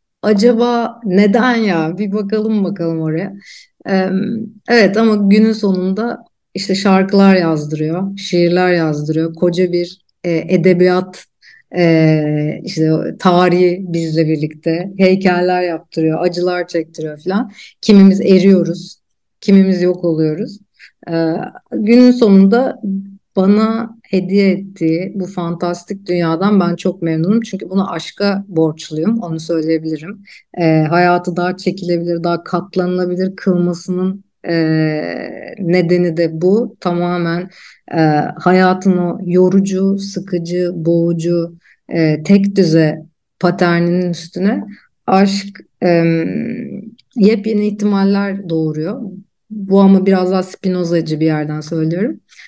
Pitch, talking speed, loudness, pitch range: 180 Hz, 100 wpm, -14 LUFS, 170-195 Hz